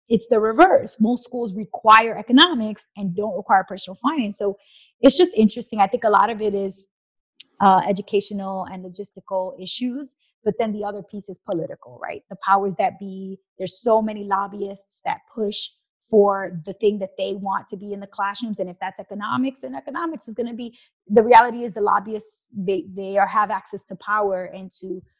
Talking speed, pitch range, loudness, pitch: 195 wpm, 195-225 Hz, -21 LUFS, 205 Hz